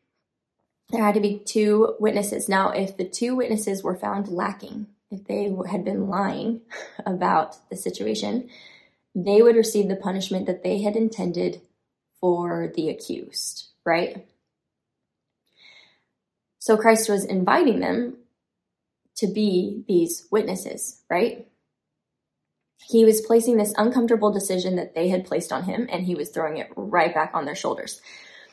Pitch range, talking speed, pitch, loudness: 185-220 Hz, 140 wpm, 205 Hz, -23 LUFS